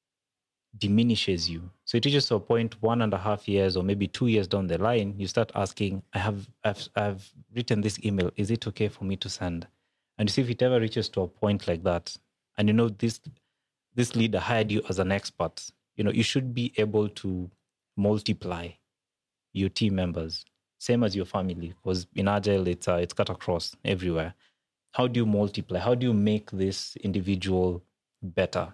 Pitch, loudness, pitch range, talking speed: 100 Hz, -28 LUFS, 95-115 Hz, 200 wpm